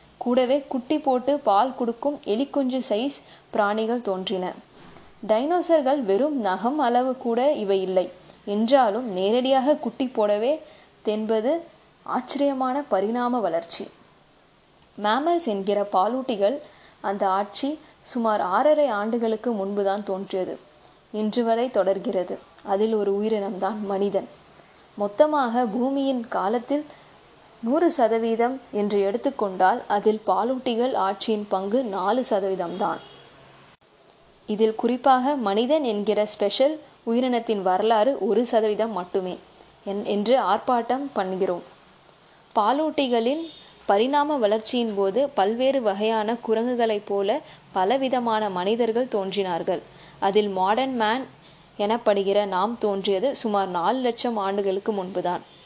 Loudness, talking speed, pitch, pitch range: -24 LUFS, 95 wpm, 220 Hz, 200-255 Hz